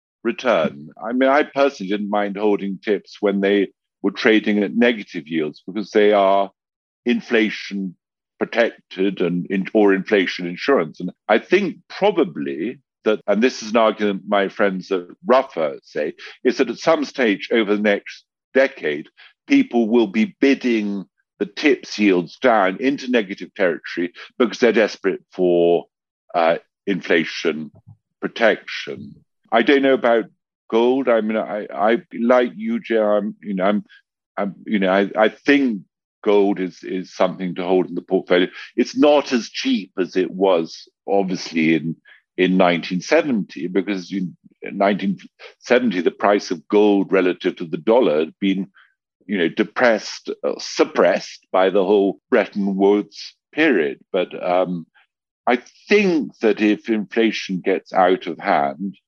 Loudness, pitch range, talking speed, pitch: -19 LUFS, 95-115 Hz, 145 wpm, 100 Hz